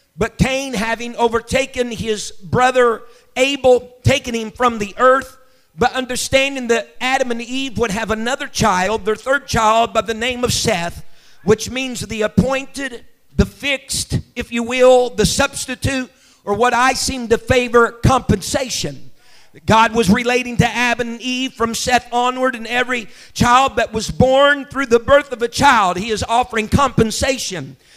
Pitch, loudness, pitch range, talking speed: 240 Hz, -16 LUFS, 225-255 Hz, 160 wpm